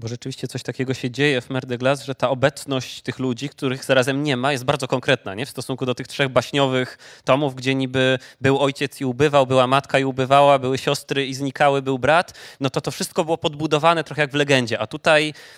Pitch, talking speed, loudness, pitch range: 135 Hz, 220 wpm, -20 LUFS, 130-145 Hz